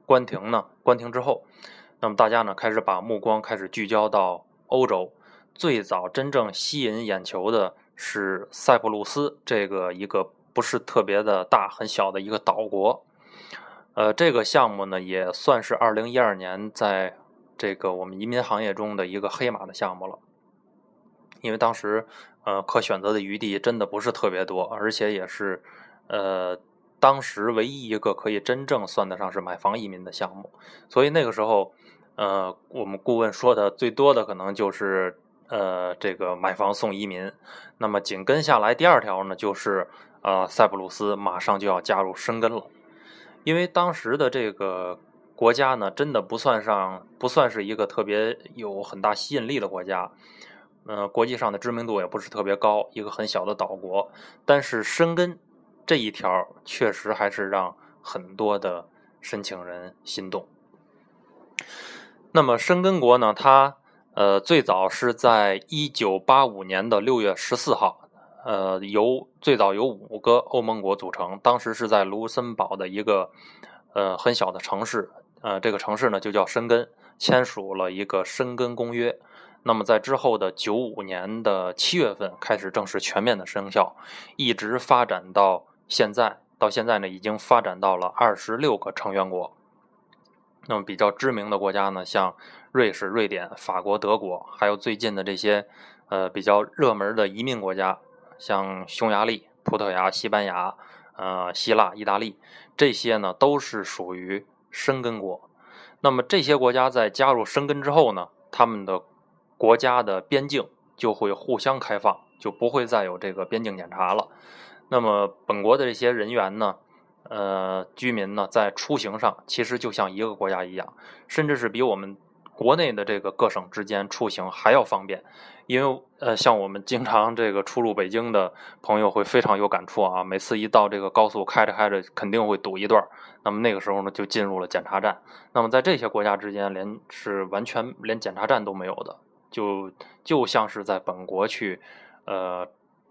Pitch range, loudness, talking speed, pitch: 95-120 Hz, -24 LUFS, 255 characters per minute, 105 Hz